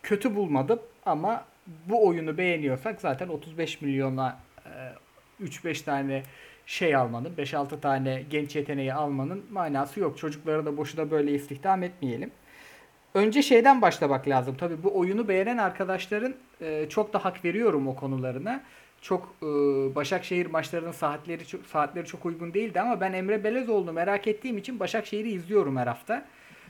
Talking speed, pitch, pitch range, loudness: 145 wpm, 170 Hz, 145-200 Hz, -28 LUFS